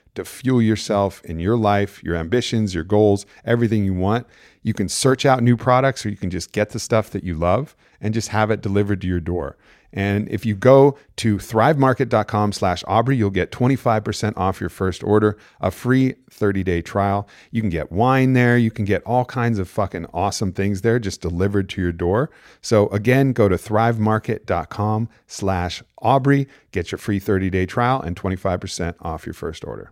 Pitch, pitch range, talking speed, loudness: 105 Hz, 95-115 Hz, 185 wpm, -20 LUFS